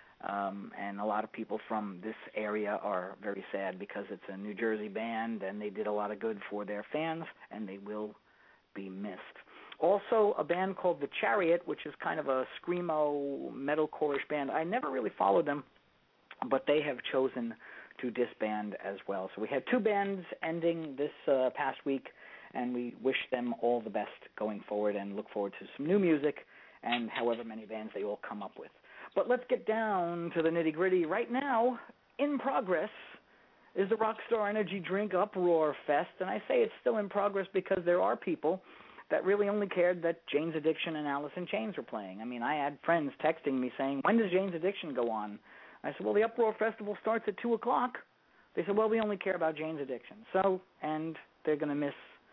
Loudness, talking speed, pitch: -34 LUFS, 205 wpm, 155 Hz